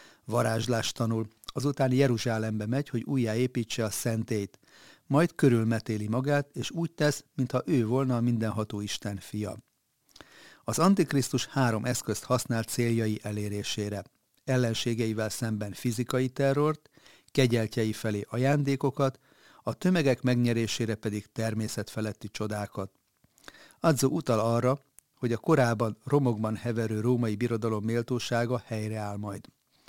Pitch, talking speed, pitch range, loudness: 120 Hz, 110 wpm, 110-135 Hz, -29 LUFS